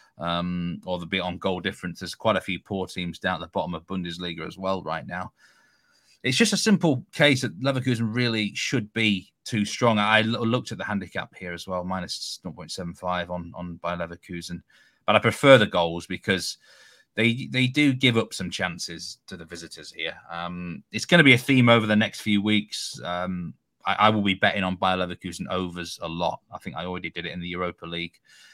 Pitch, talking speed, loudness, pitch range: 95 Hz, 210 wpm, -24 LUFS, 85-115 Hz